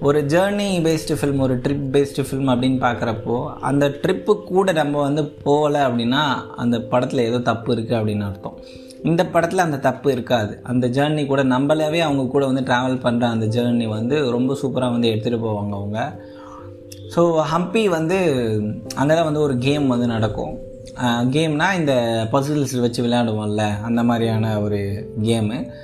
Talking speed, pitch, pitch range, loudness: 155 wpm, 130 Hz, 115-145 Hz, -20 LUFS